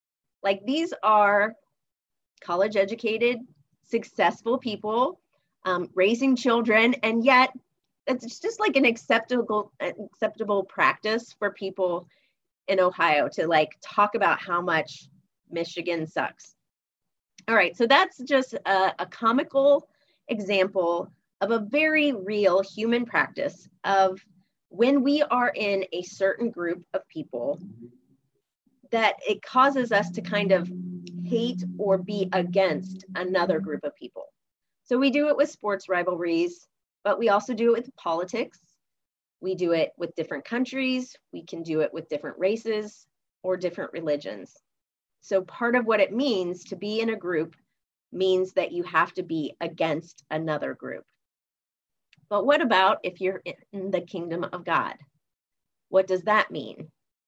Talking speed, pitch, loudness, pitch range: 140 wpm, 195 Hz, -25 LUFS, 175-235 Hz